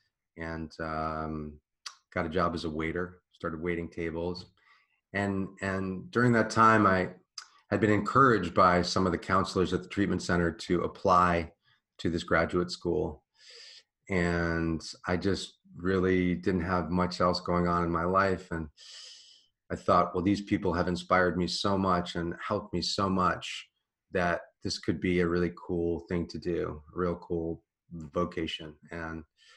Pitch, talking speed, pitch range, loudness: 90 Hz, 160 wpm, 85-95 Hz, -29 LUFS